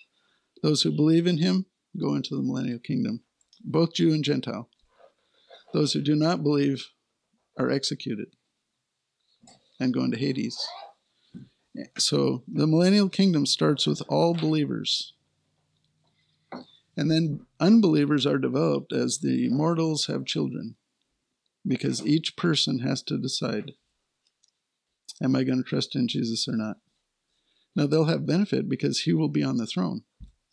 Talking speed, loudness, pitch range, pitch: 135 wpm, -25 LUFS, 130-165 Hz, 150 Hz